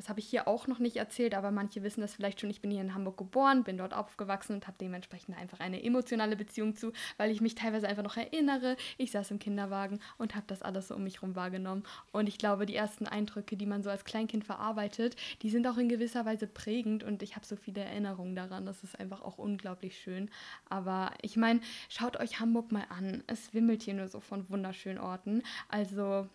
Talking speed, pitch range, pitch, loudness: 230 wpm, 195-225 Hz, 210 Hz, -36 LUFS